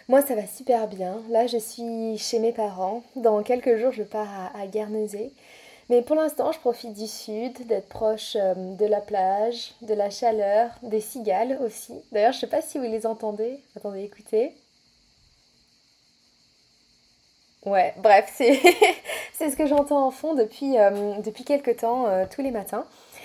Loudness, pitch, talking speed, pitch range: -24 LUFS, 225 Hz, 160 wpm, 210-245 Hz